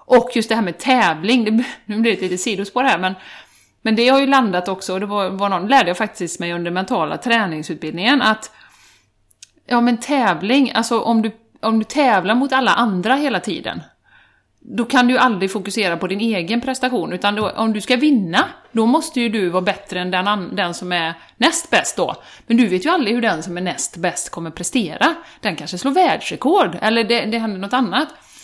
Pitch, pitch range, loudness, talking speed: 225 Hz, 185-255 Hz, -18 LUFS, 210 wpm